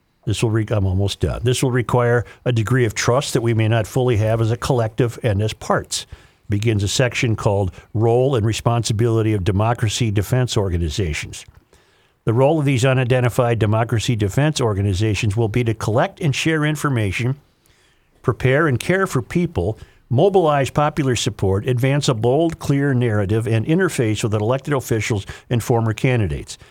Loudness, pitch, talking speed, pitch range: -19 LUFS, 120 Hz, 160 wpm, 110-130 Hz